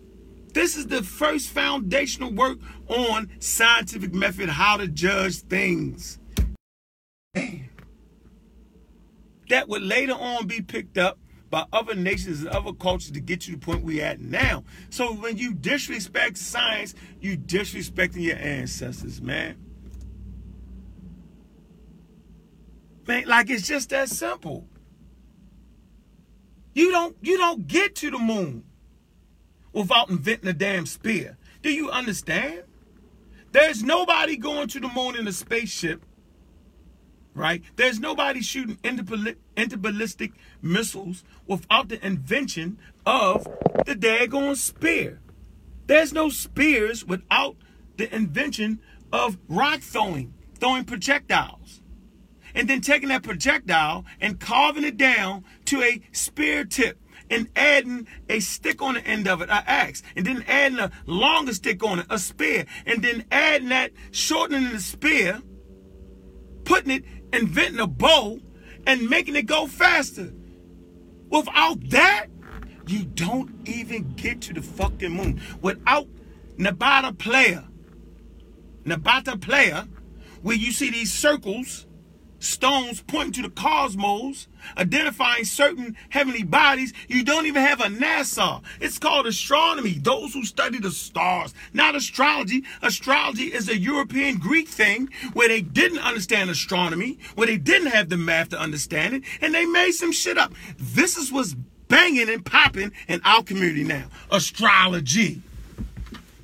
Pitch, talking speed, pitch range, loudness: 230 Hz, 130 wpm, 185-275 Hz, -22 LUFS